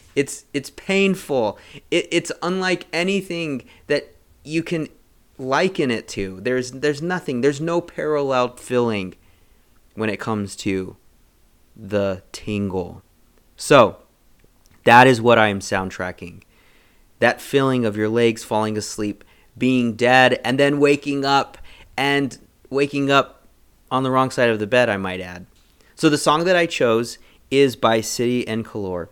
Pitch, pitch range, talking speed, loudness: 125 Hz, 105-140 Hz, 145 wpm, -20 LUFS